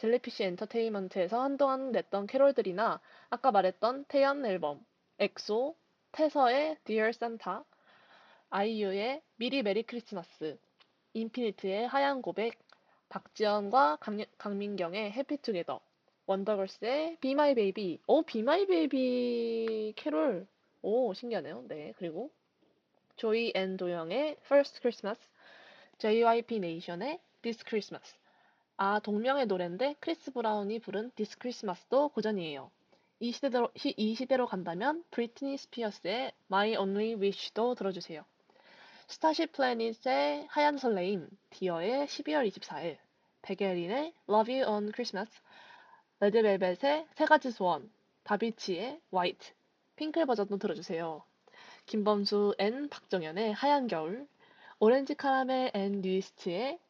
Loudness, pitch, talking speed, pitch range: -32 LUFS, 225 Hz, 325 characters per minute, 200-275 Hz